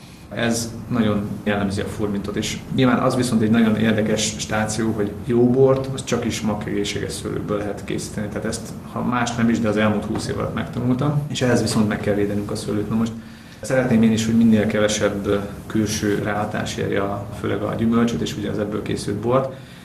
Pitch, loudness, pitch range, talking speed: 110 Hz, -21 LUFS, 105-115 Hz, 195 wpm